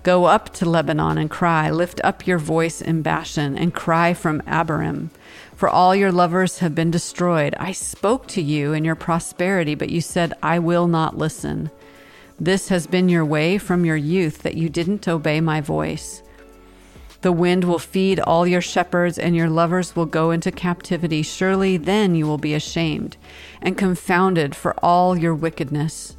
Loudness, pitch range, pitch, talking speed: -20 LUFS, 155-180 Hz, 170 Hz, 175 wpm